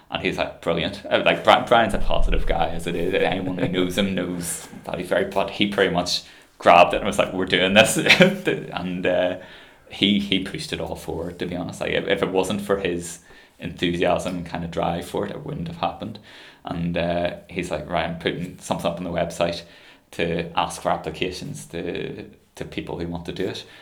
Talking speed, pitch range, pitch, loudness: 215 wpm, 85-95 Hz, 90 Hz, -22 LUFS